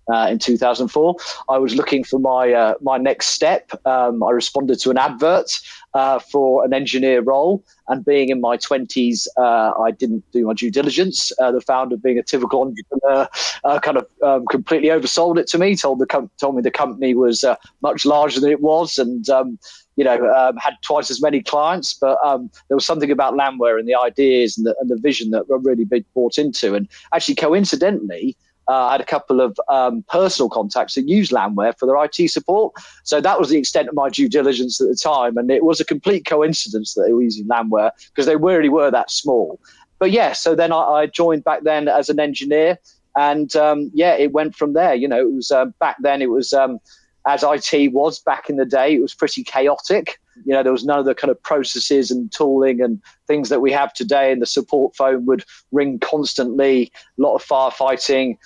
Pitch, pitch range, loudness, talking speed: 135 Hz, 125-150 Hz, -17 LUFS, 220 wpm